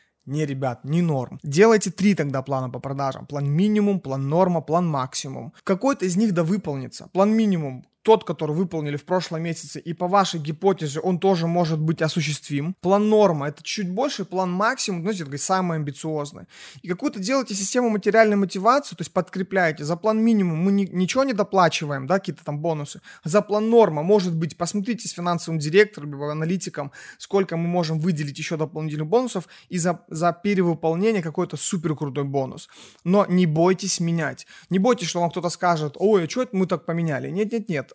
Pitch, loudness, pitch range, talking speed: 175 Hz, -22 LUFS, 155-200 Hz, 180 wpm